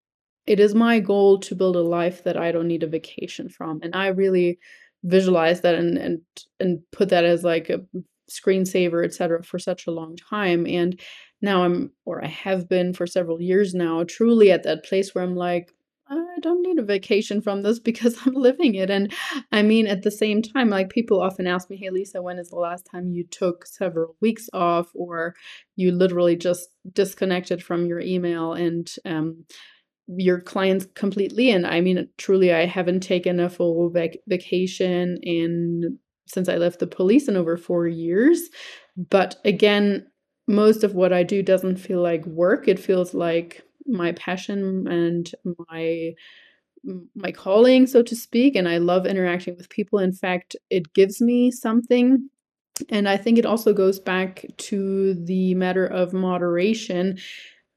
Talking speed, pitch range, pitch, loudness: 175 wpm, 175-205 Hz, 185 Hz, -22 LUFS